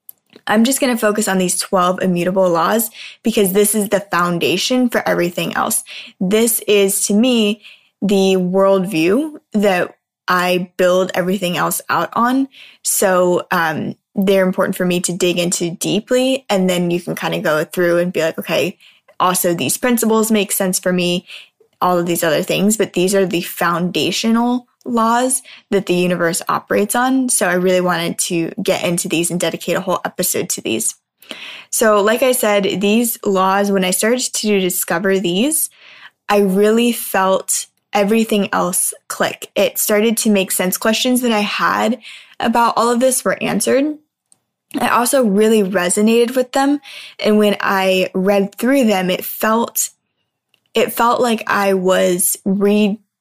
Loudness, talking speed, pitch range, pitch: -16 LUFS, 160 wpm, 180-225 Hz, 200 Hz